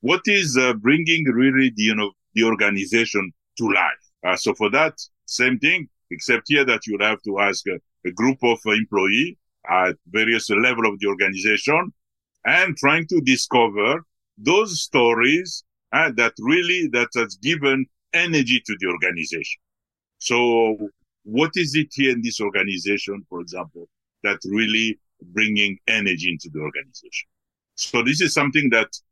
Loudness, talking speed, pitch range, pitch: -19 LUFS, 155 wpm, 100-135 Hz, 115 Hz